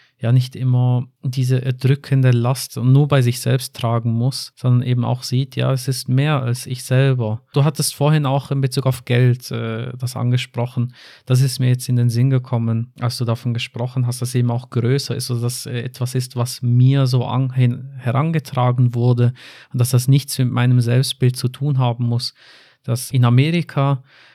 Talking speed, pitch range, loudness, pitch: 190 wpm, 120-135 Hz, -19 LUFS, 125 Hz